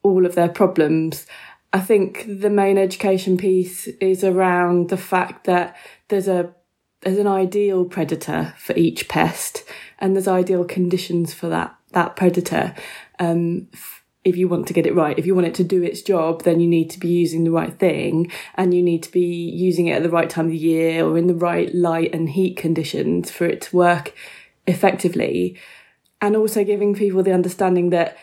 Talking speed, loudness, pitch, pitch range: 195 wpm, -19 LUFS, 180 Hz, 170-190 Hz